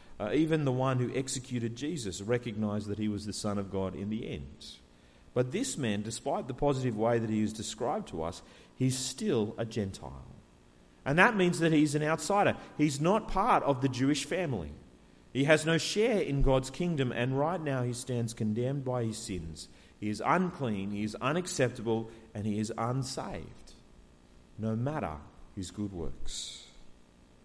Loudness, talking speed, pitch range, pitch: -31 LUFS, 175 wpm, 100-140 Hz, 115 Hz